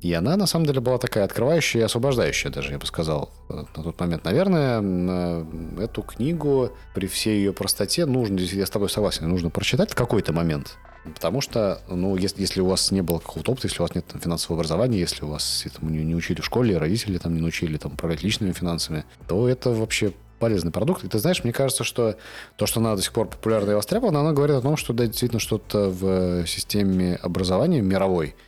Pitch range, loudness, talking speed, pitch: 85-115 Hz, -23 LUFS, 210 wpm, 95 Hz